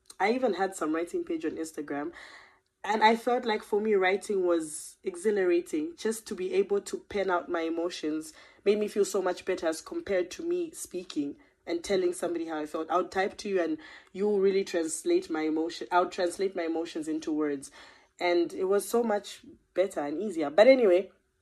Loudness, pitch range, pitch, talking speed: -29 LUFS, 170-220 Hz, 190 Hz, 195 wpm